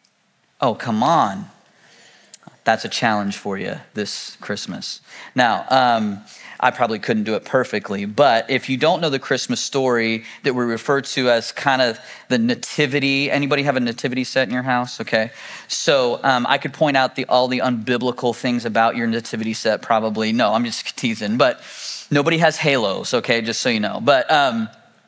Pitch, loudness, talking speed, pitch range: 125 Hz, -19 LUFS, 180 wpm, 115-140 Hz